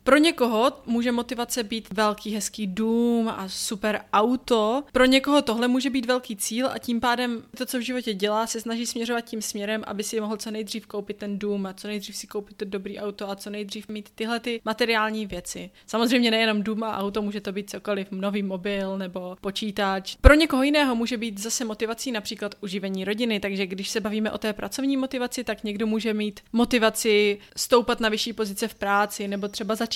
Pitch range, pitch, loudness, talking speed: 205-235 Hz, 220 Hz, -25 LUFS, 200 wpm